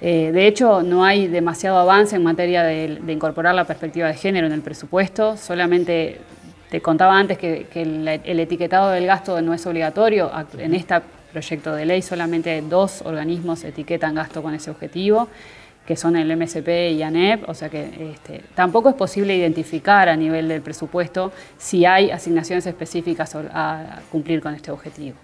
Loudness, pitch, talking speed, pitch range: -19 LUFS, 170 Hz, 175 wpm, 160-180 Hz